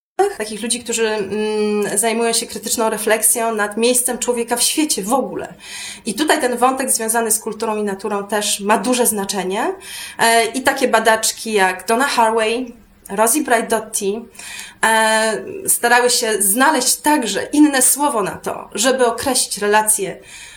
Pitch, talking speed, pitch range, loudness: 230 Hz, 135 wpm, 215-245 Hz, -16 LUFS